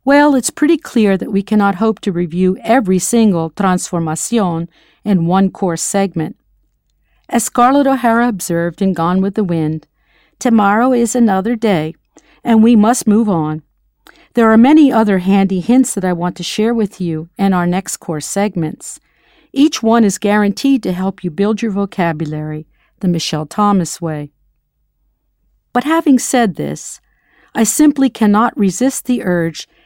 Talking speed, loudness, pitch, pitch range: 155 wpm, -14 LUFS, 200 Hz, 175-235 Hz